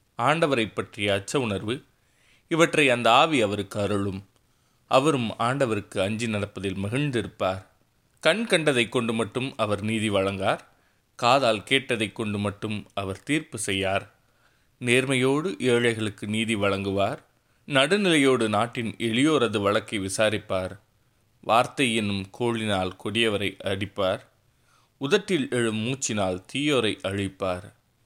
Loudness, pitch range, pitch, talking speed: -25 LUFS, 100-125 Hz, 110 Hz, 100 wpm